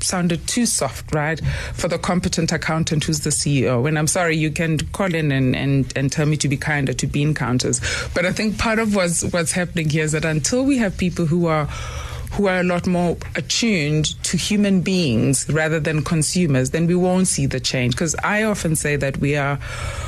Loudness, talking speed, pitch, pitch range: -19 LUFS, 210 wpm, 160 Hz, 145-180 Hz